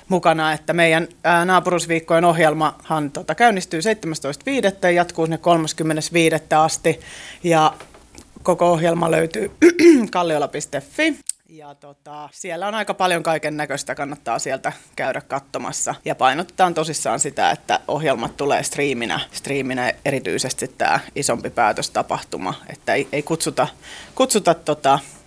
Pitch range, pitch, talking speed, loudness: 150-180 Hz, 165 Hz, 115 wpm, -19 LUFS